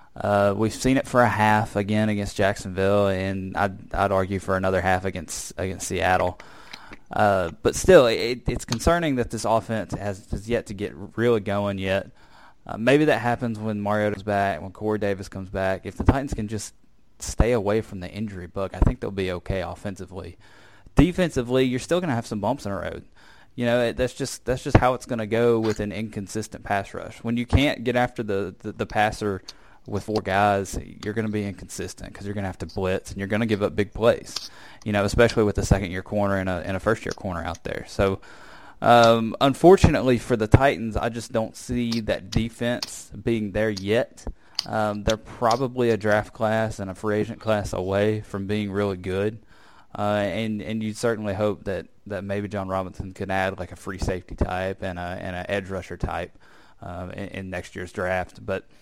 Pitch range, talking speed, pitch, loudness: 95-115 Hz, 210 wpm, 105 Hz, -24 LUFS